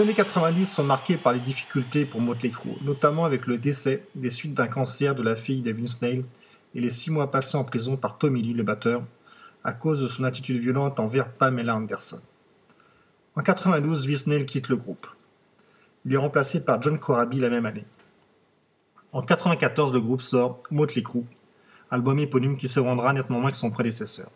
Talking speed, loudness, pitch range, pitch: 195 wpm, -25 LUFS, 120-150 Hz, 130 Hz